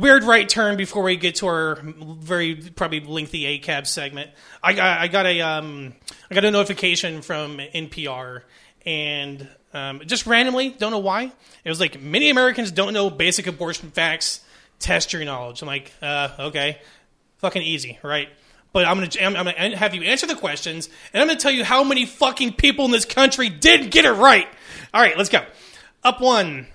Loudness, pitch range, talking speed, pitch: -19 LUFS, 150-215 Hz, 195 wpm, 180 Hz